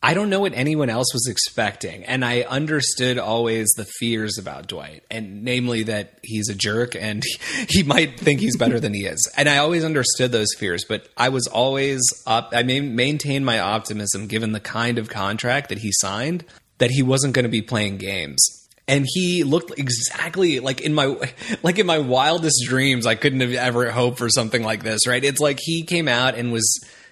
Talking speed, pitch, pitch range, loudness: 210 wpm, 125 Hz, 110-140 Hz, -20 LUFS